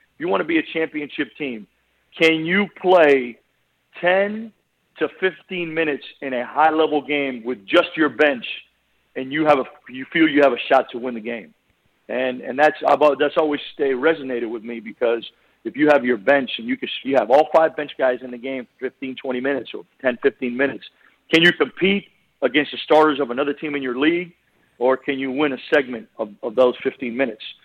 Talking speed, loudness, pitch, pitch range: 210 wpm, -20 LUFS, 145 Hz, 130-160 Hz